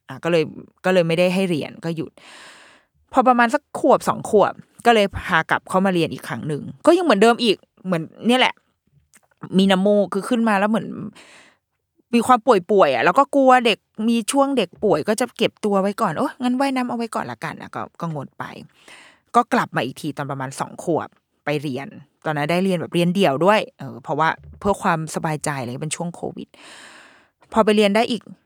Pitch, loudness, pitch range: 200 Hz, -20 LUFS, 170-235 Hz